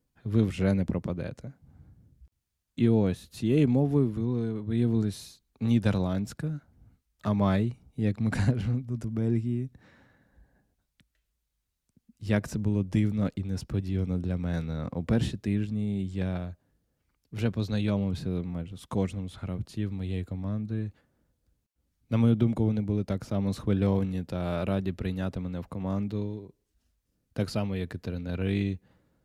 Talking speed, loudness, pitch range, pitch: 115 wpm, -29 LUFS, 95-110 Hz, 100 Hz